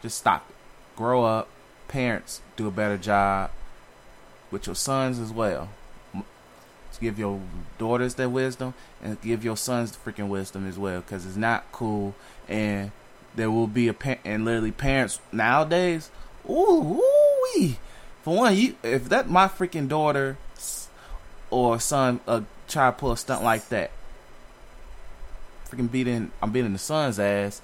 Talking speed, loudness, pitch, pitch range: 150 wpm, -25 LUFS, 115 Hz, 100-130 Hz